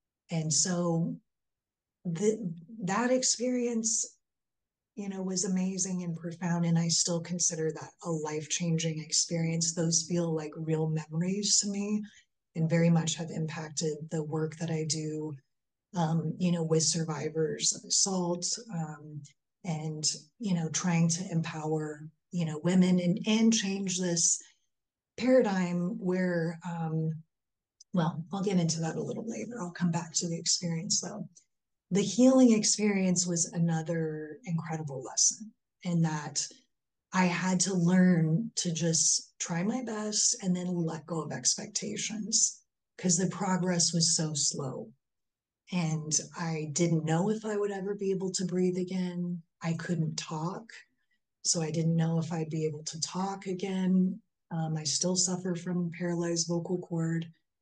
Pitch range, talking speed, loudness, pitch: 160-190 Hz, 145 wpm, -30 LUFS, 170 Hz